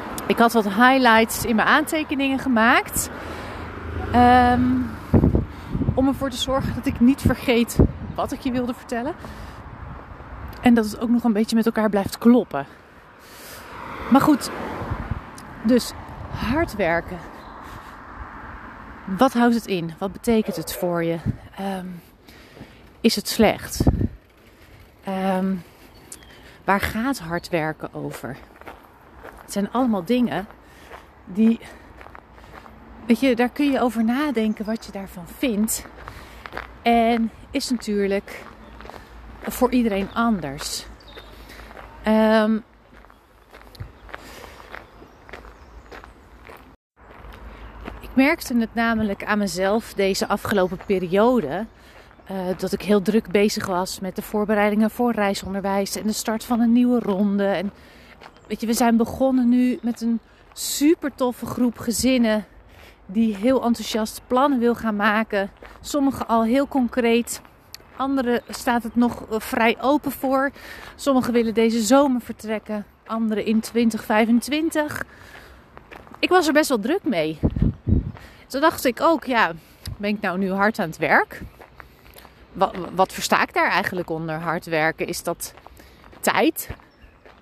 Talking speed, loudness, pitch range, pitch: 125 wpm, -21 LUFS, 200-250 Hz, 225 Hz